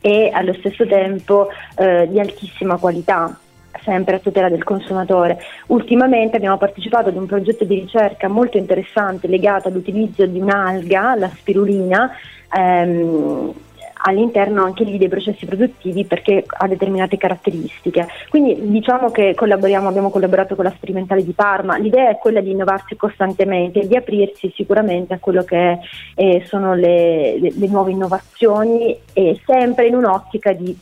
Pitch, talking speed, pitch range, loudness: 195 Hz, 150 wpm, 185-210 Hz, -16 LUFS